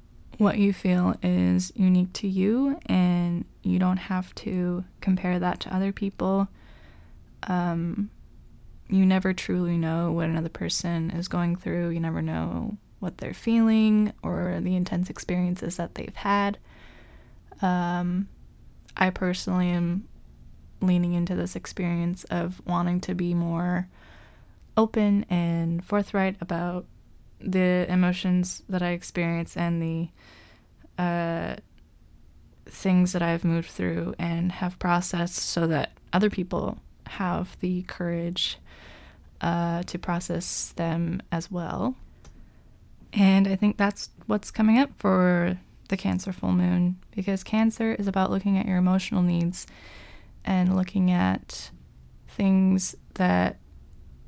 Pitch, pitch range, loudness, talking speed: 180 Hz, 170-190 Hz, -26 LUFS, 125 wpm